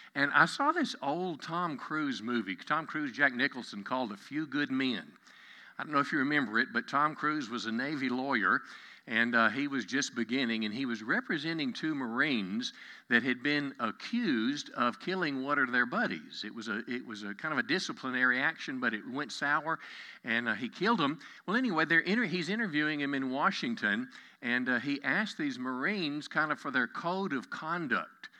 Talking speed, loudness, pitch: 200 wpm, -32 LUFS, 150 Hz